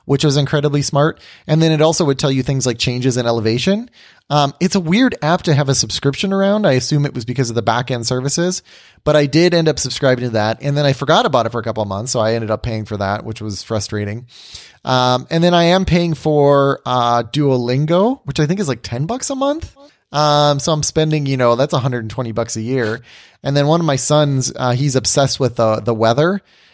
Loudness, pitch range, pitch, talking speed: -16 LUFS, 120-155 Hz, 140 Hz, 240 wpm